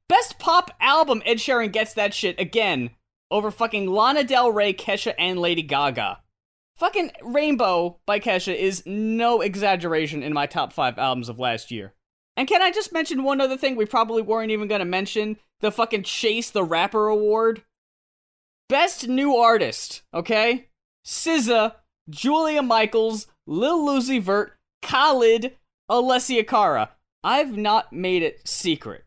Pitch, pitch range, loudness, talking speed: 220 Hz, 190-250 Hz, -22 LUFS, 145 wpm